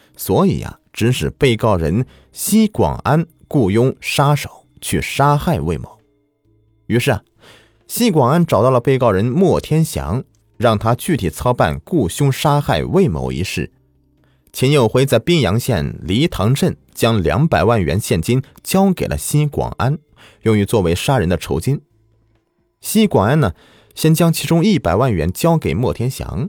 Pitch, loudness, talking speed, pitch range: 125 Hz, -16 LUFS, 225 characters per minute, 110-150 Hz